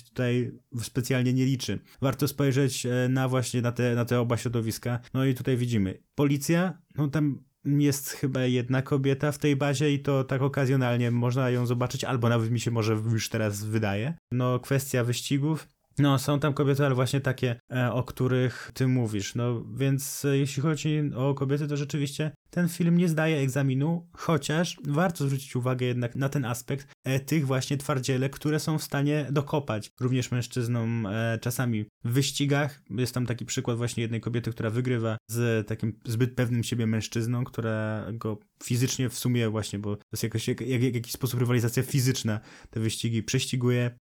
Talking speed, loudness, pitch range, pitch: 170 wpm, -28 LUFS, 120-140 Hz, 130 Hz